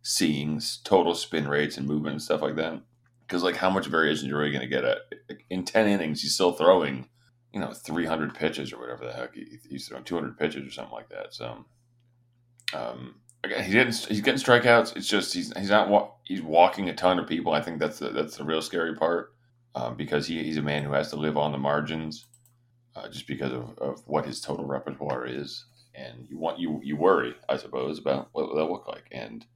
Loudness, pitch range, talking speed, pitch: -27 LUFS, 75-120 Hz, 230 wpm, 80 Hz